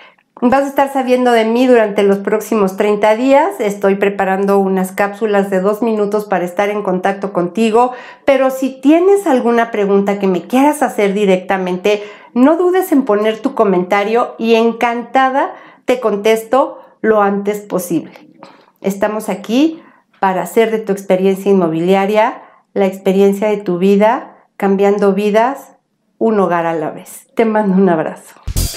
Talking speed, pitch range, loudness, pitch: 145 wpm, 195-245 Hz, -14 LUFS, 210 Hz